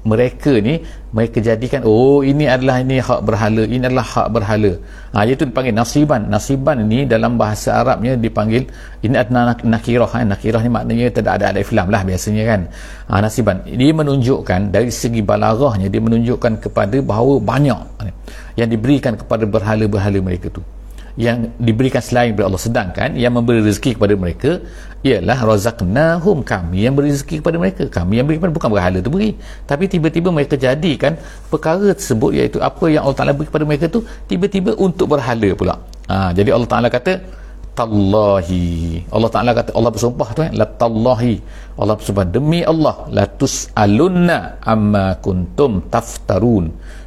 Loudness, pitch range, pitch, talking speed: -15 LUFS, 105-135 Hz, 115 Hz, 160 wpm